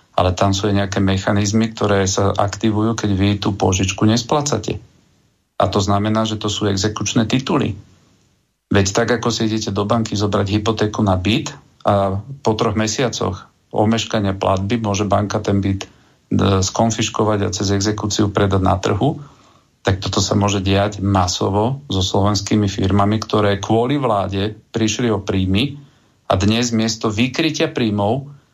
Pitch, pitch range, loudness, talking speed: 105 Hz, 100-115 Hz, -18 LUFS, 145 wpm